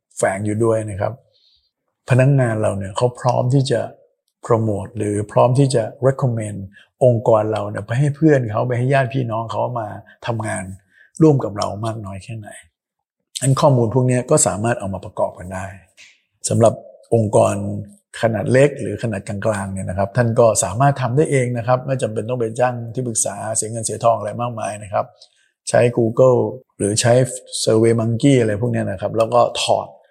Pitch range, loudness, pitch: 105-125 Hz, -18 LUFS, 115 Hz